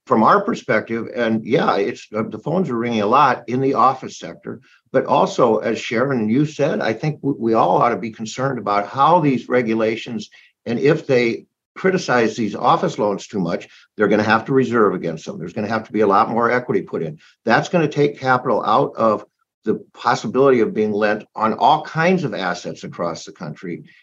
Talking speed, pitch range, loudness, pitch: 215 wpm, 110-140 Hz, -18 LUFS, 115 Hz